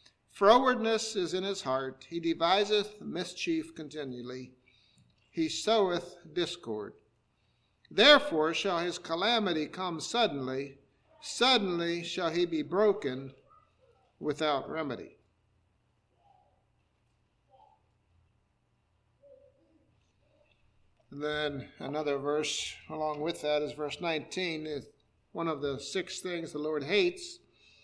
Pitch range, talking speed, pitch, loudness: 130-185 Hz, 95 wpm, 155 Hz, -30 LUFS